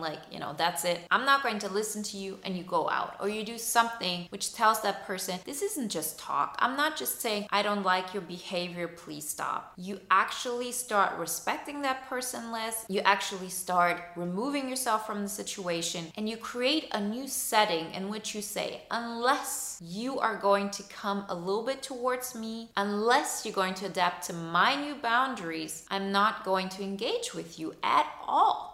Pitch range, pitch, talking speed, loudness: 185-235 Hz, 200 Hz, 195 wpm, -30 LUFS